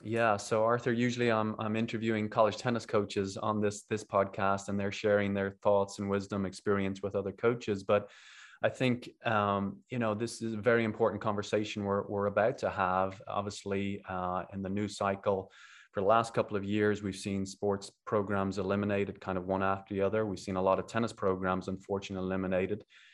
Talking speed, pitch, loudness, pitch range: 190 wpm, 100 Hz, -32 LUFS, 95-110 Hz